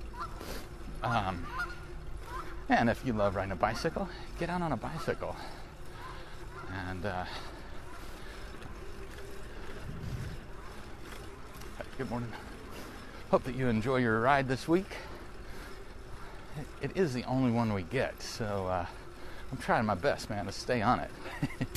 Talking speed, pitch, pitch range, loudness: 120 wpm, 120 Hz, 105-135 Hz, -33 LUFS